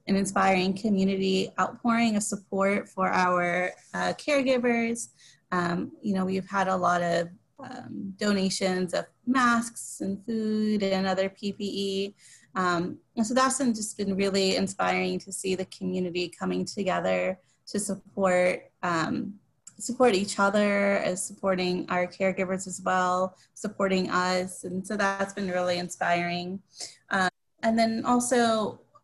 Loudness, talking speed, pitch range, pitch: -27 LUFS, 135 wpm, 185-215 Hz, 195 Hz